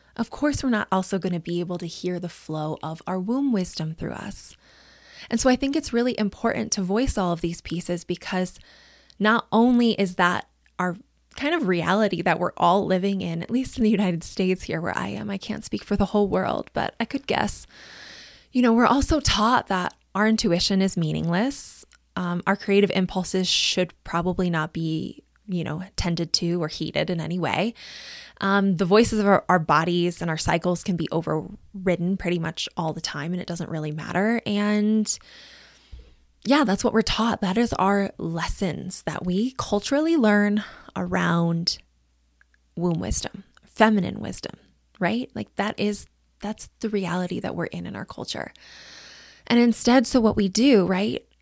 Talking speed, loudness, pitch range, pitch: 180 wpm, -24 LUFS, 175-220 Hz, 190 Hz